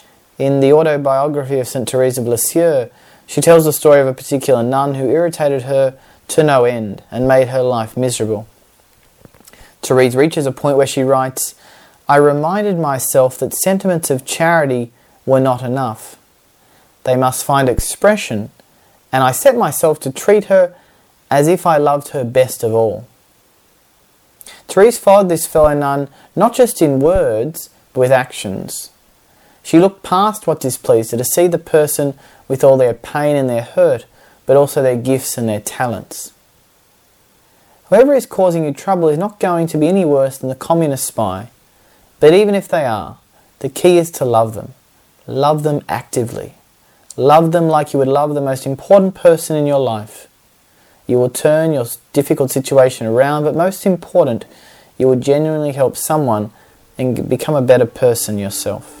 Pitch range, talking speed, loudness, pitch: 130-160 Hz, 165 wpm, -14 LUFS, 140 Hz